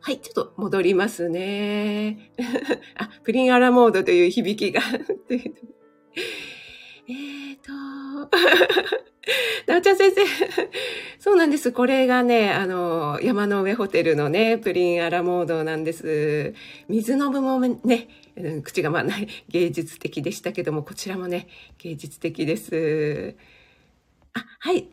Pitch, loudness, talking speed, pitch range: 225 Hz, -22 LUFS, 250 characters per minute, 175-275 Hz